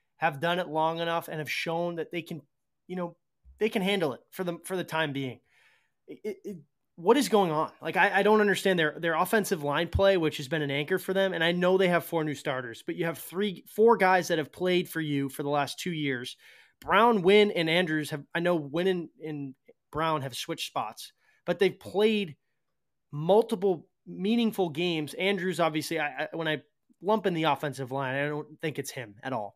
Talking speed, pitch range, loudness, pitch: 220 wpm, 150-190 Hz, -28 LUFS, 170 Hz